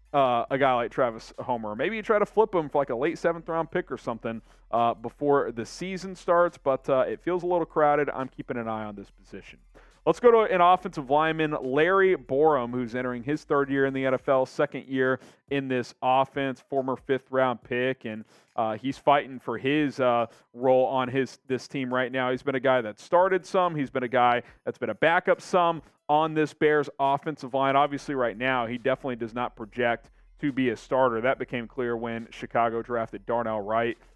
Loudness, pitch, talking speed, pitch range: -26 LUFS, 135 Hz, 210 wpm, 125-150 Hz